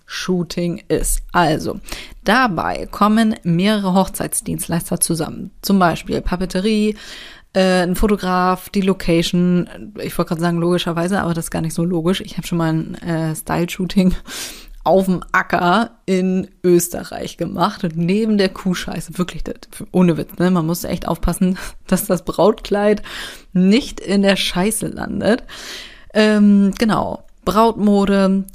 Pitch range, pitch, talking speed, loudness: 175-200 Hz, 185 Hz, 135 wpm, -18 LUFS